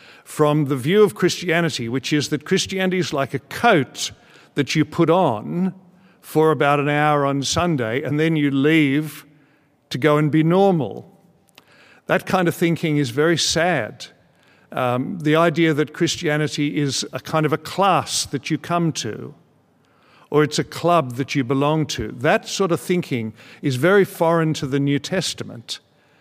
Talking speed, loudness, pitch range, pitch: 165 wpm, -20 LUFS, 145-170 Hz, 150 Hz